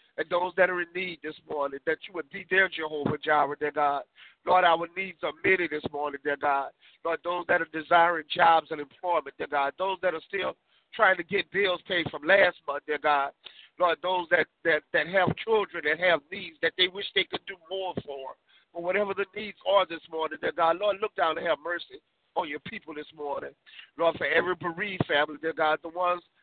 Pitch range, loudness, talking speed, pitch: 150-185 Hz, -27 LUFS, 220 wpm, 170 Hz